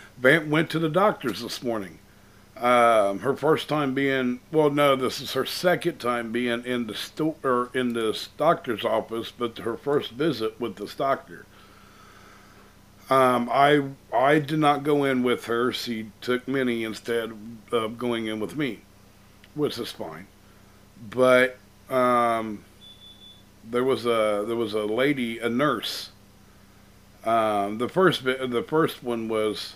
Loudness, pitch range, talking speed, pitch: -24 LUFS, 105-135 Hz, 150 wpm, 120 Hz